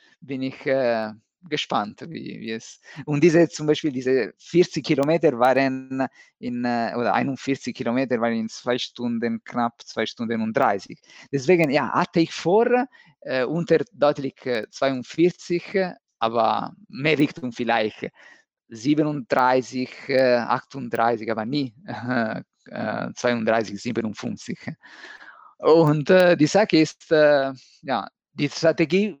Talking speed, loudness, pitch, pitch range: 120 wpm, -22 LUFS, 135 Hz, 120-160 Hz